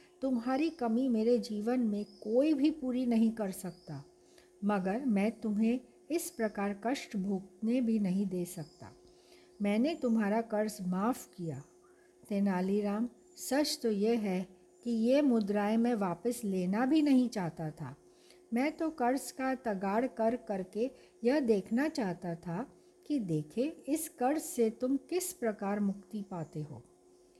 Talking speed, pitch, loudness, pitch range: 140 wpm, 225 Hz, -33 LUFS, 195-265 Hz